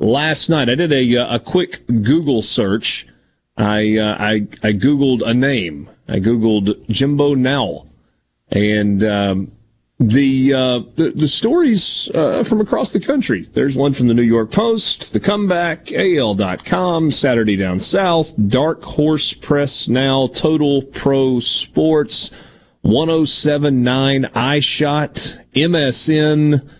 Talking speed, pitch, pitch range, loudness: 130 wpm, 135 Hz, 115-155 Hz, -15 LUFS